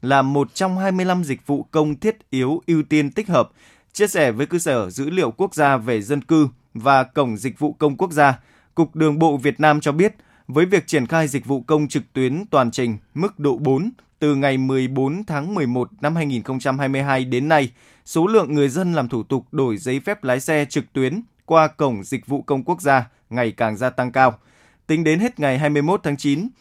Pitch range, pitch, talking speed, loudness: 130-160 Hz, 145 Hz, 215 wpm, -20 LUFS